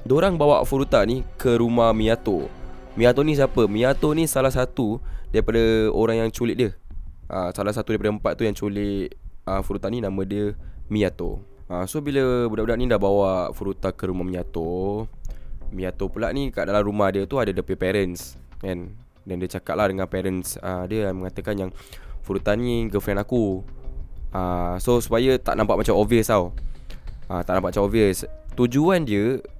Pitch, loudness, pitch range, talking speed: 100 Hz, -23 LUFS, 90-115 Hz, 160 wpm